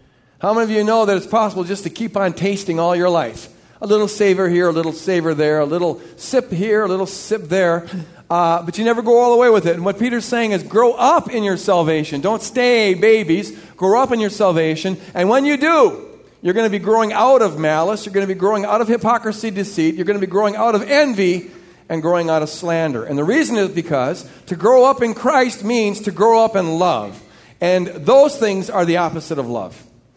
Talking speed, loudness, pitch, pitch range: 235 wpm, -16 LUFS, 195 Hz, 170-225 Hz